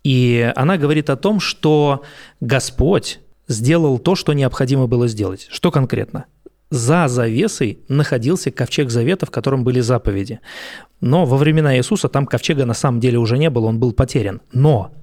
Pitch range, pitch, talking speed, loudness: 125-155 Hz, 135 Hz, 160 wpm, -17 LUFS